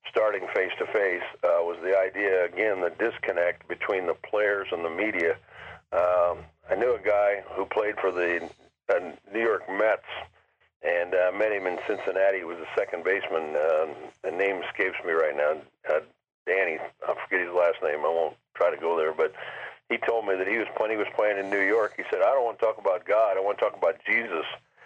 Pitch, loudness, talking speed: 100 Hz, -27 LUFS, 215 wpm